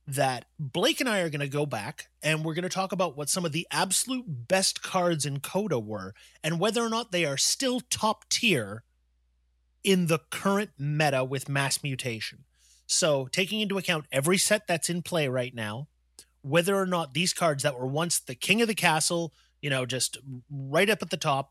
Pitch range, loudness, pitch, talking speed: 135-185 Hz, -27 LUFS, 155 Hz, 205 wpm